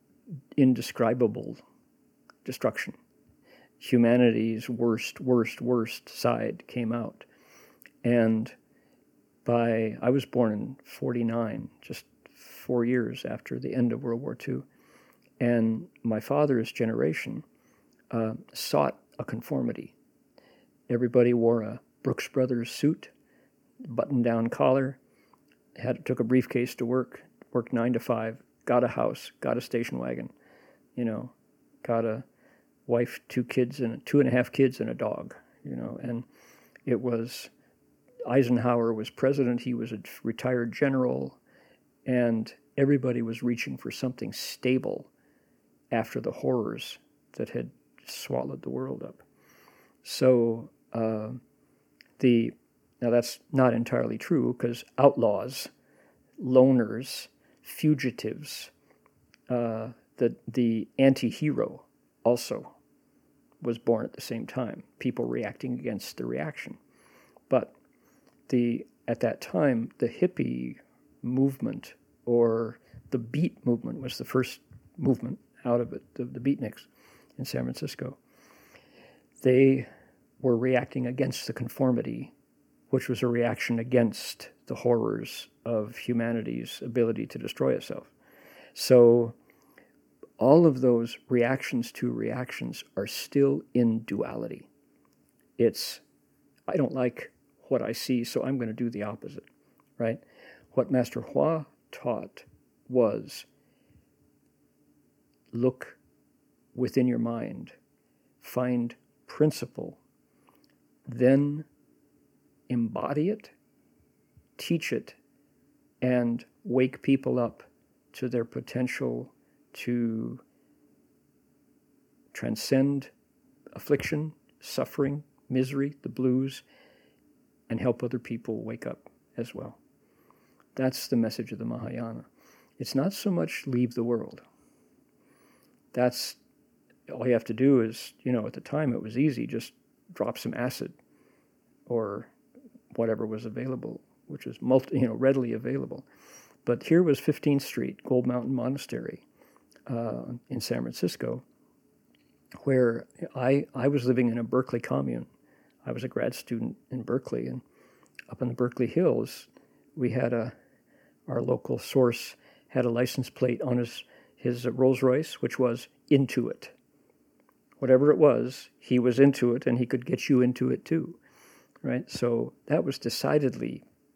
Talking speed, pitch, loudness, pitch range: 125 wpm, 125 Hz, -28 LUFS, 115-130 Hz